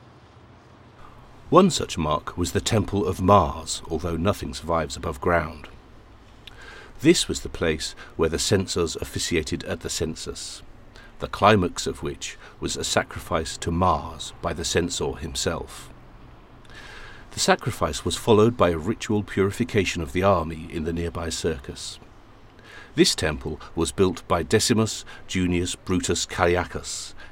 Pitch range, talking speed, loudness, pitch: 85-105 Hz, 135 wpm, -24 LUFS, 90 Hz